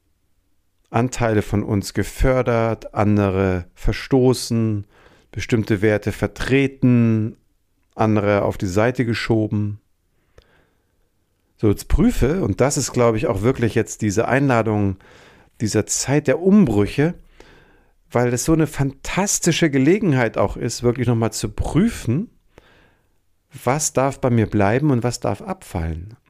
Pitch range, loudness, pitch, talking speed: 100-130 Hz, -19 LUFS, 110 Hz, 120 wpm